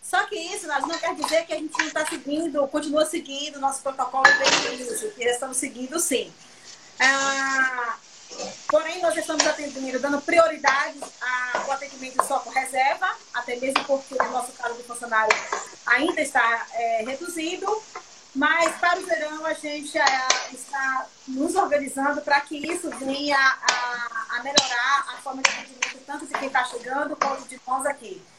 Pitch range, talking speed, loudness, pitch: 260-315 Hz, 165 wpm, -24 LUFS, 280 Hz